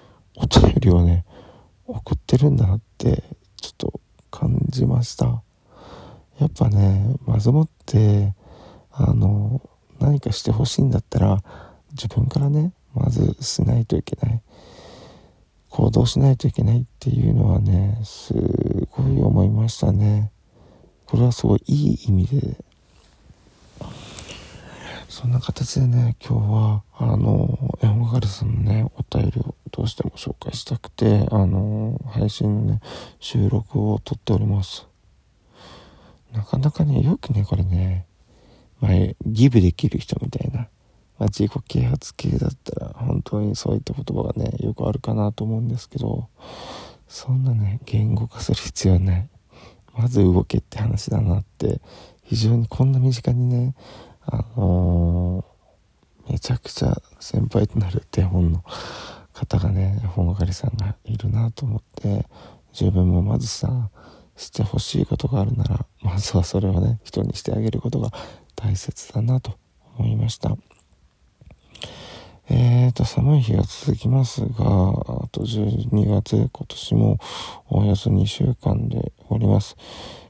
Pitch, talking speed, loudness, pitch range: 110 Hz, 260 characters per minute, -21 LUFS, 100-125 Hz